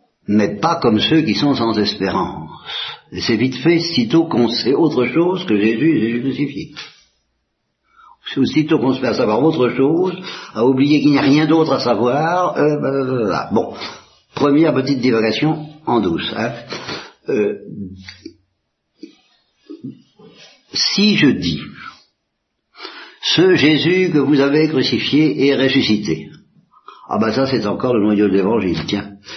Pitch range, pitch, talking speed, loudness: 115-155 Hz, 135 Hz, 140 wpm, -16 LUFS